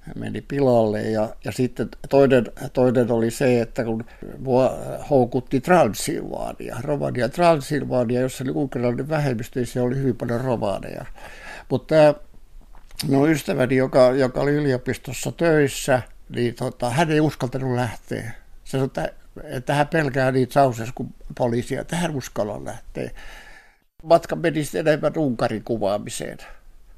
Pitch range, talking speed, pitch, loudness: 120-145 Hz, 125 wpm, 130 Hz, -22 LUFS